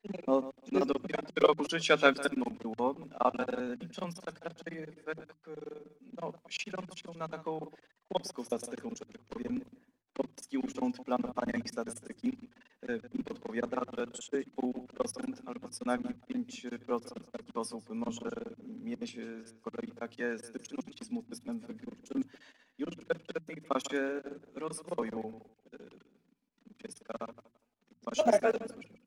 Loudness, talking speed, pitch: -36 LUFS, 105 wpm, 195 Hz